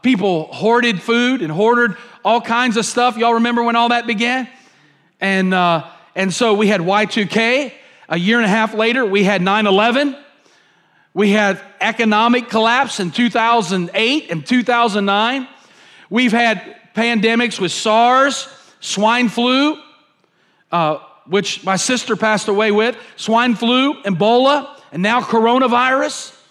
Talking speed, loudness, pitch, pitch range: 135 wpm, -15 LUFS, 230 Hz, 205-245 Hz